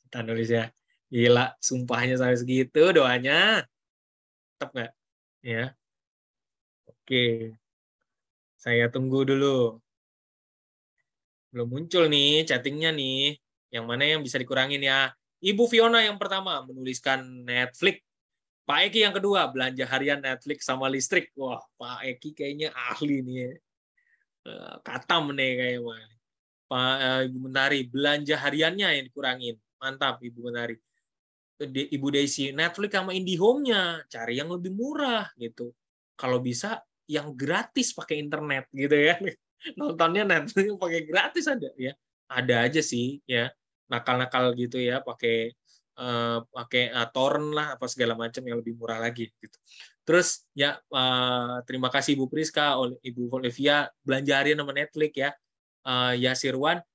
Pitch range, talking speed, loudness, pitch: 125-150 Hz, 130 wpm, -26 LUFS, 130 Hz